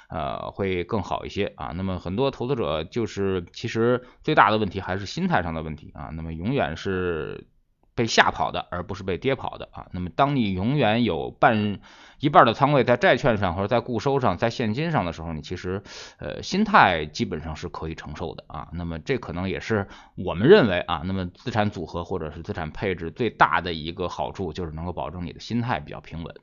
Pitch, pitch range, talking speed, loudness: 95 Hz, 85-110 Hz, 320 characters per minute, -24 LUFS